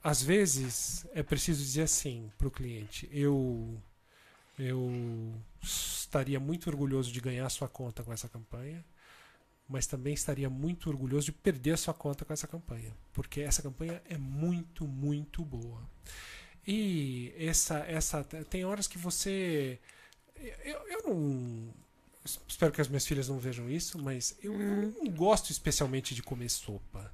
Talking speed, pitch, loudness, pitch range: 155 wpm, 145 Hz, -34 LUFS, 125-160 Hz